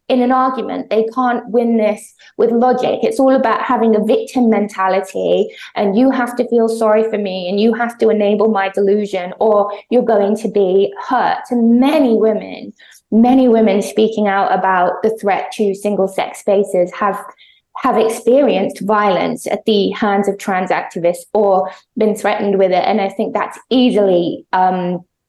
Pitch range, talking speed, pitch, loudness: 200-240 Hz, 170 wpm, 215 Hz, -15 LUFS